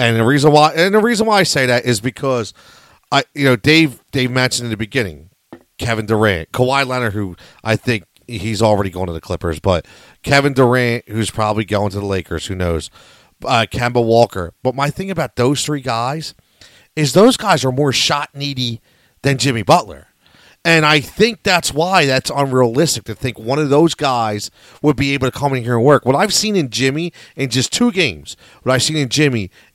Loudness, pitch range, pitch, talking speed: -15 LUFS, 110-150 Hz, 130 Hz, 205 wpm